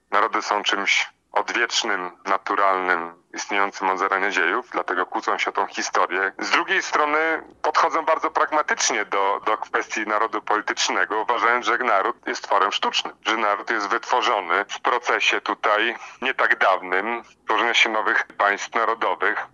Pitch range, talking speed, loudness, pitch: 95-155 Hz, 145 wpm, -21 LUFS, 105 Hz